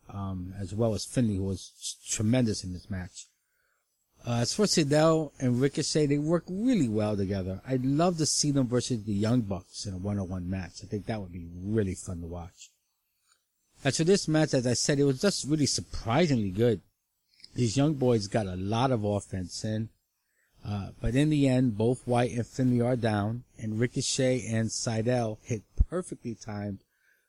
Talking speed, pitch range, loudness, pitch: 190 wpm, 100-135 Hz, -29 LUFS, 115 Hz